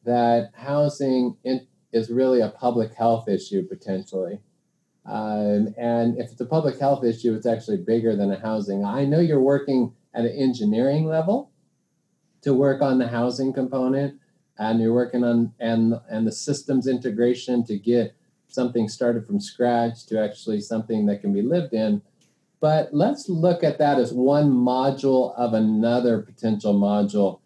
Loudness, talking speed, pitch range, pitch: -23 LUFS, 155 wpm, 115-140 Hz, 120 Hz